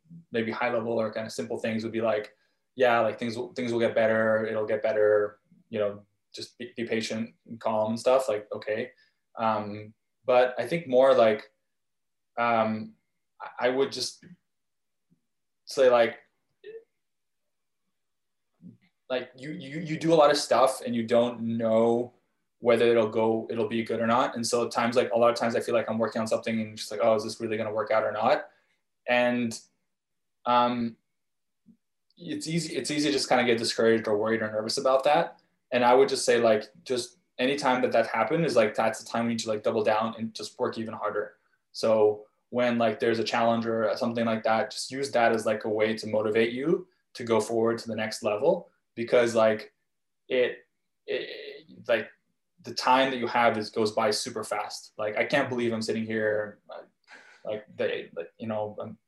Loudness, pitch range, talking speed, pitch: -27 LUFS, 110-125 Hz, 200 wpm, 115 Hz